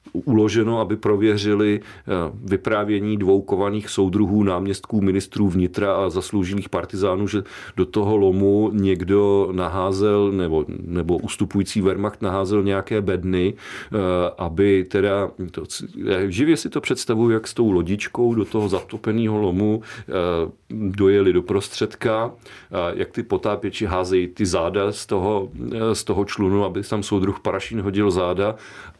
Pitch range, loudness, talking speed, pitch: 95-105 Hz, -21 LUFS, 125 wpm, 100 Hz